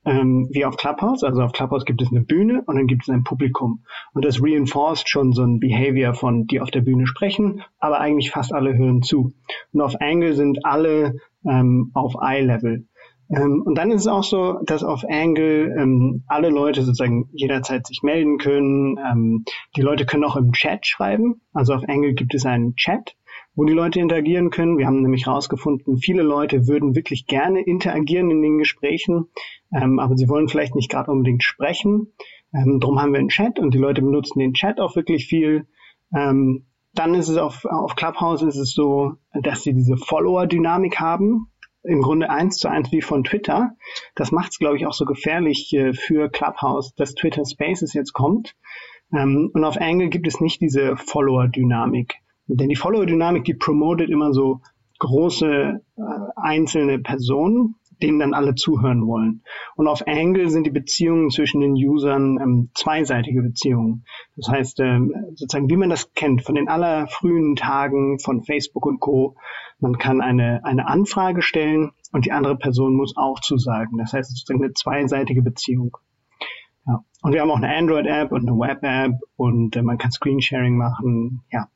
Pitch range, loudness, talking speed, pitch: 130-160 Hz, -19 LUFS, 185 wpm, 140 Hz